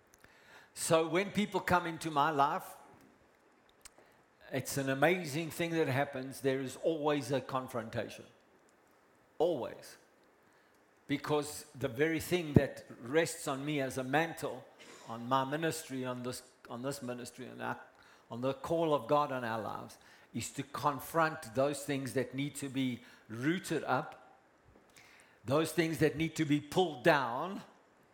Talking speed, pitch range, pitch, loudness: 145 wpm, 130-160 Hz, 145 Hz, -34 LUFS